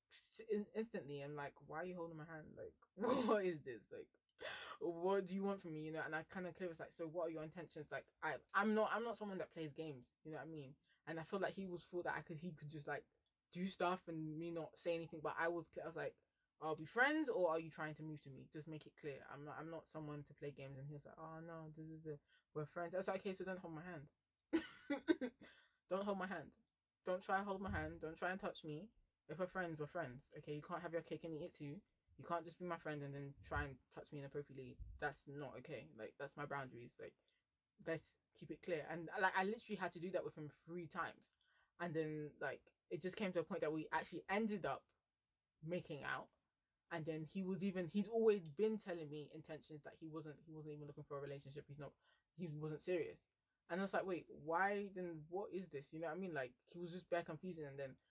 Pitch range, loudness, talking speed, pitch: 150-185 Hz, -46 LUFS, 255 wpm, 165 Hz